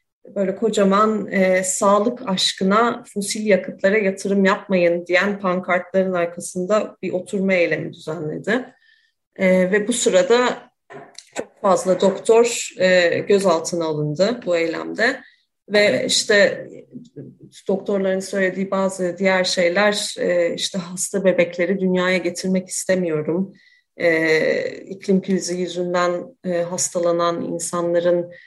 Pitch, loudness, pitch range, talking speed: 190 Hz, -19 LUFS, 175-205 Hz, 105 wpm